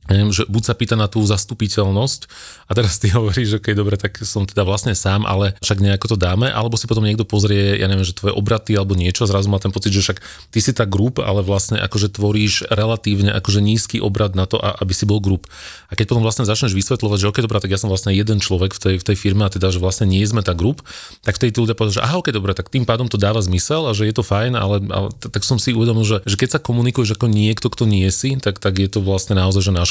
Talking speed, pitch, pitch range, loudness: 265 wpm, 105 Hz, 100-115 Hz, -17 LUFS